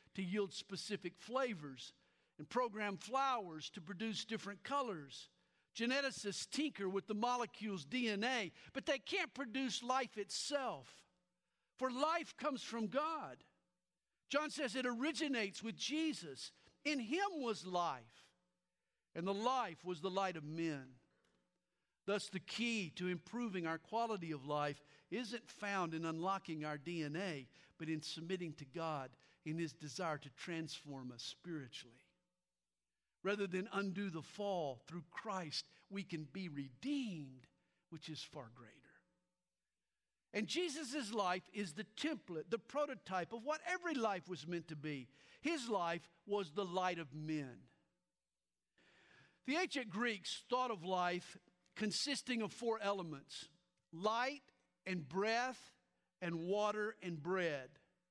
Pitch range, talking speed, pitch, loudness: 160-240 Hz, 130 wpm, 195 Hz, -42 LUFS